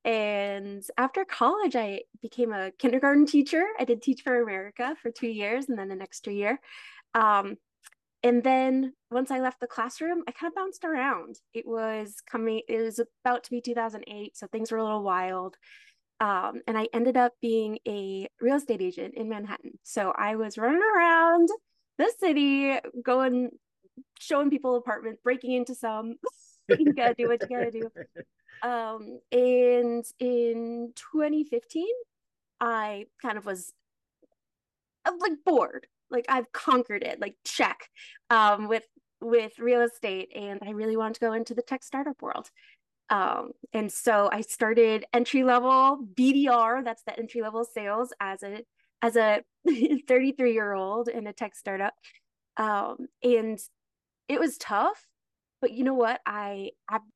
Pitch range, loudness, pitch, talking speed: 220-265 Hz, -27 LUFS, 235 Hz, 160 wpm